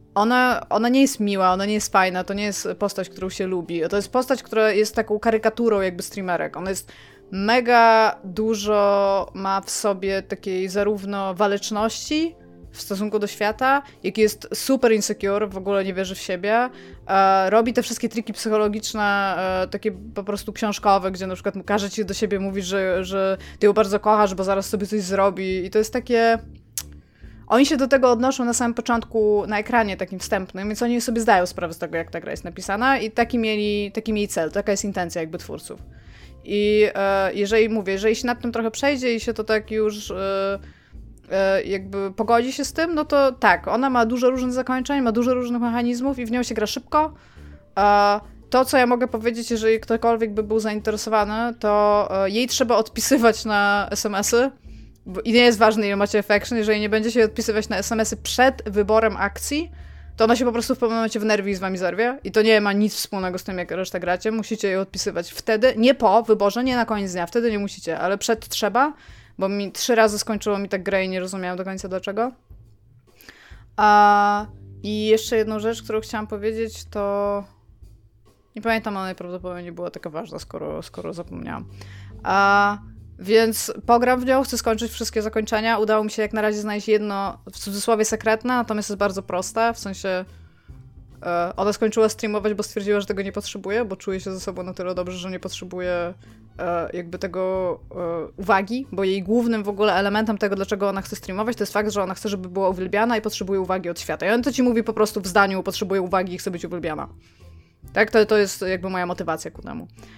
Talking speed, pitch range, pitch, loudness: 200 wpm, 190-225 Hz, 210 Hz, -21 LUFS